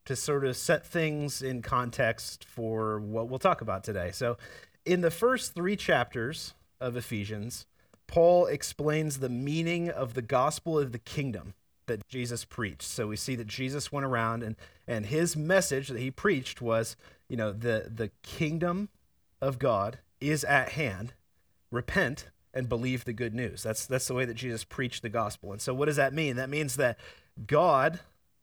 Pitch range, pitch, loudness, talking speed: 115-150 Hz, 125 Hz, -30 LUFS, 175 wpm